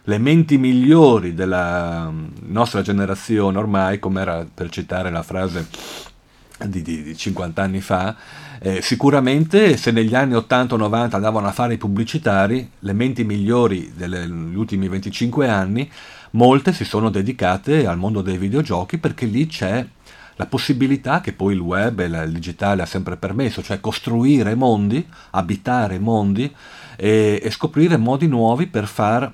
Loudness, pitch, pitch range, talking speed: -19 LUFS, 105 Hz, 95-125 Hz, 150 wpm